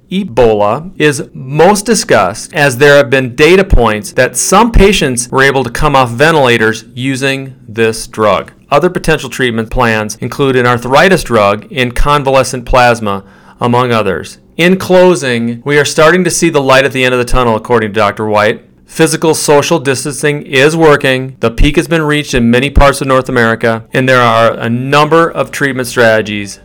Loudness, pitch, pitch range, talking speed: -9 LUFS, 130 Hz, 115-150 Hz, 175 wpm